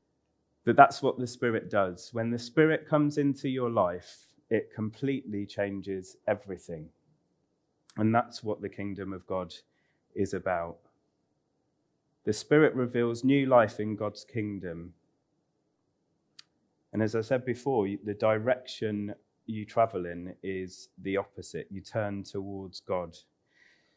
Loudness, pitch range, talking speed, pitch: -30 LUFS, 95-120 Hz, 130 wpm, 105 Hz